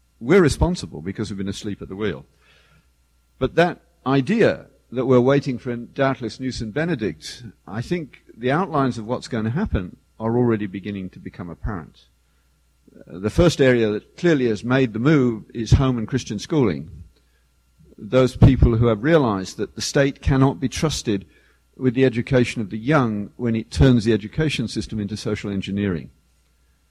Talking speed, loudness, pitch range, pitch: 170 wpm, -21 LUFS, 100-130 Hz, 115 Hz